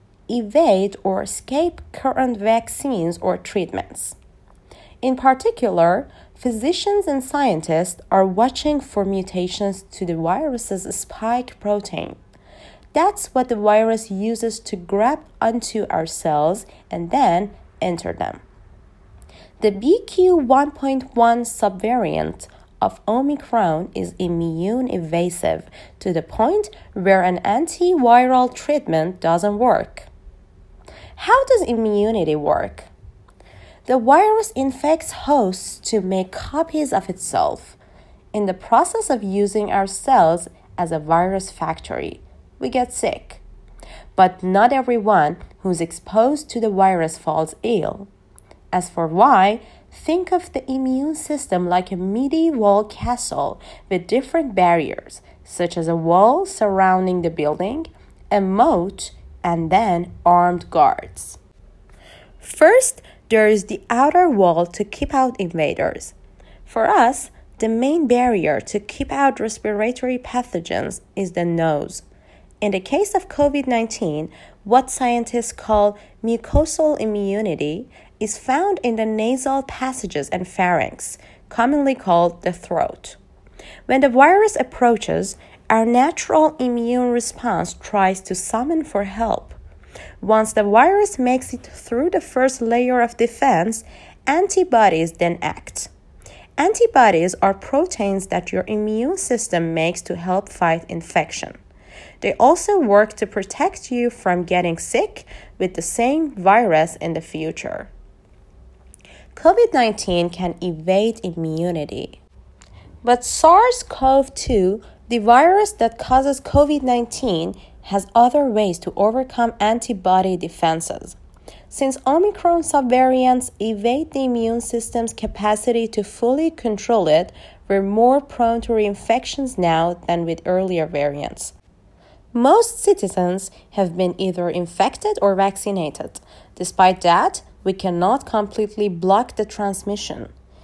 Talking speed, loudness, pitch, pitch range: 120 wpm, -19 LUFS, 215 Hz, 180-260 Hz